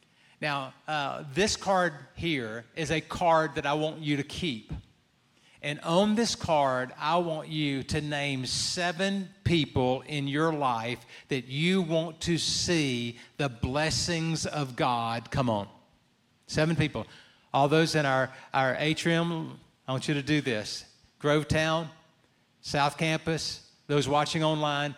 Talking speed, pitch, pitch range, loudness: 140 wpm, 150 Hz, 135-160 Hz, -28 LUFS